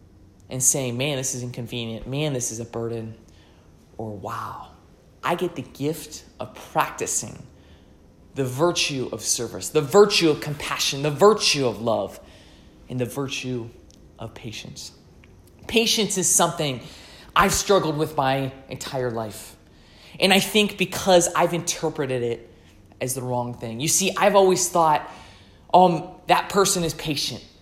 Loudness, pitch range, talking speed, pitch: -22 LUFS, 105-165 Hz, 145 wpm, 130 Hz